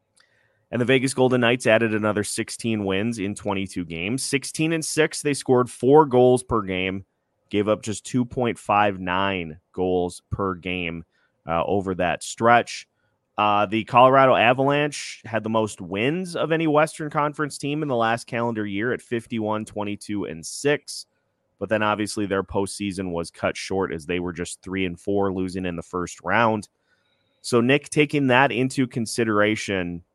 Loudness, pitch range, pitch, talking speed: -23 LUFS, 95-130 Hz, 110 Hz, 160 wpm